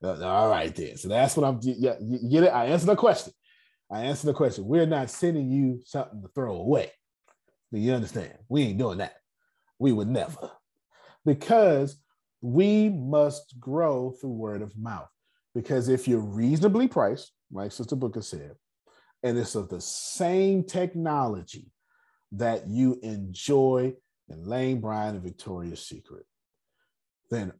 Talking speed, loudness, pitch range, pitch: 150 wpm, -26 LUFS, 110-155 Hz, 130 Hz